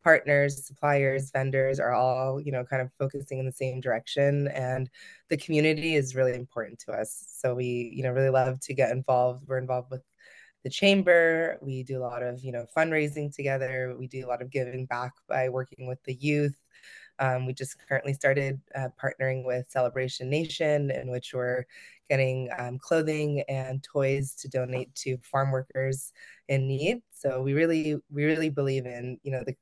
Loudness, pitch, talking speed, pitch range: -28 LUFS, 135 Hz, 185 wpm, 130-140 Hz